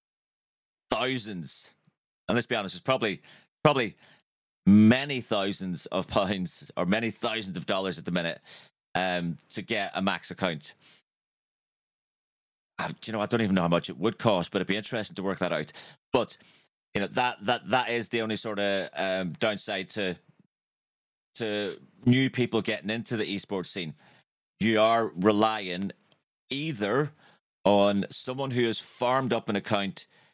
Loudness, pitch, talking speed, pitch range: -28 LUFS, 110 Hz, 160 wpm, 95-120 Hz